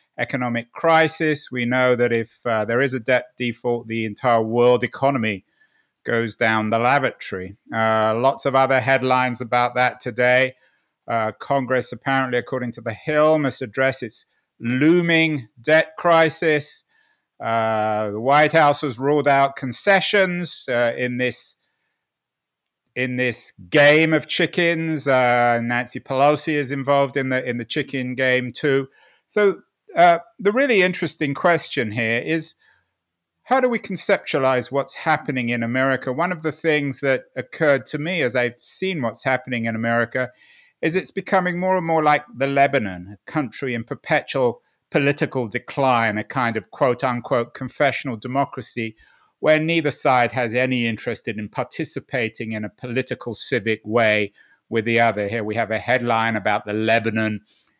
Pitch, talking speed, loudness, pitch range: 130 Hz, 150 wpm, -20 LUFS, 120-150 Hz